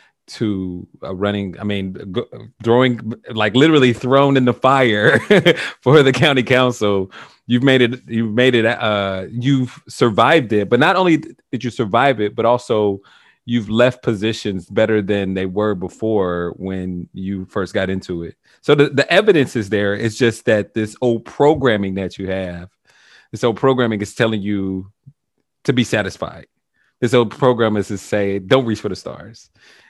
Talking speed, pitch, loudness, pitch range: 165 wpm, 115 Hz, -17 LUFS, 100-125 Hz